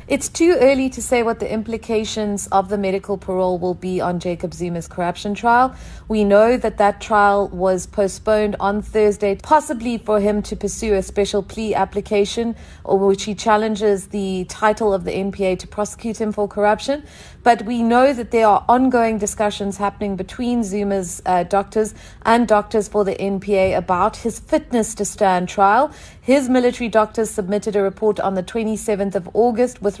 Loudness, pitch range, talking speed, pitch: -19 LUFS, 195-225 Hz, 175 wpm, 210 Hz